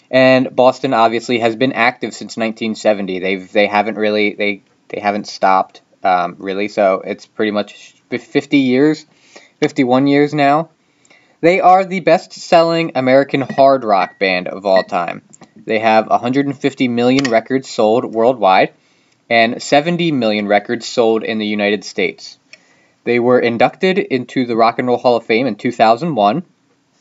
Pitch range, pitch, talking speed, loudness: 110-140 Hz, 125 Hz, 150 wpm, -15 LUFS